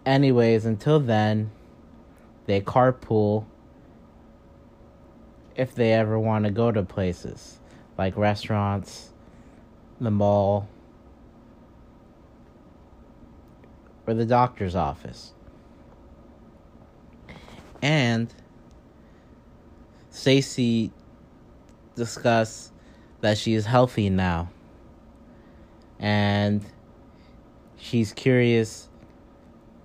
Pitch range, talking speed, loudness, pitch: 100-115 Hz, 65 wpm, -24 LUFS, 110 Hz